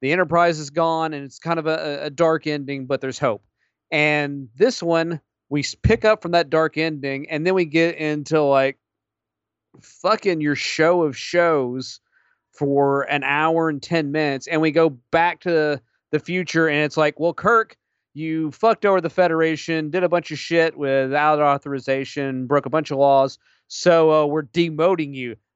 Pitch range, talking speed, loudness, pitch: 140-165 Hz, 180 wpm, -20 LUFS, 155 Hz